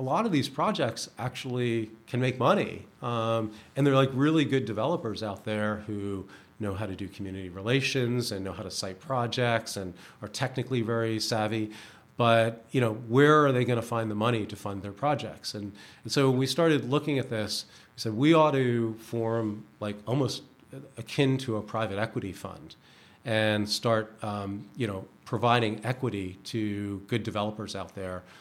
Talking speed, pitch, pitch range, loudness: 180 wpm, 115 Hz, 105-125 Hz, -29 LUFS